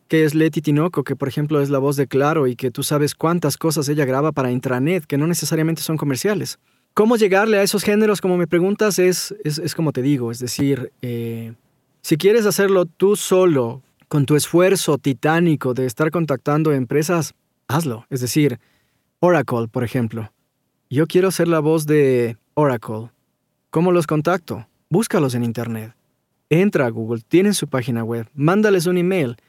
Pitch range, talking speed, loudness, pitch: 130-175 Hz, 175 wpm, -19 LUFS, 150 Hz